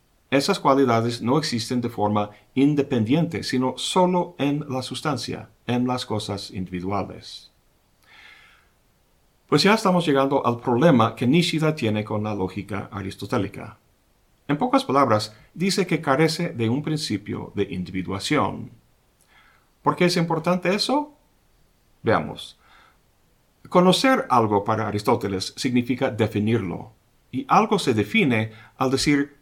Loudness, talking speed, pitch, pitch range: -22 LUFS, 120 wpm, 125 Hz, 105-145 Hz